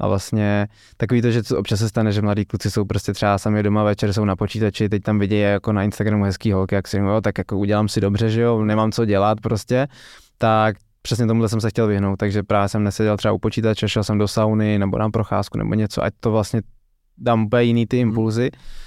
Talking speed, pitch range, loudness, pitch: 240 wpm, 105-110 Hz, -20 LUFS, 105 Hz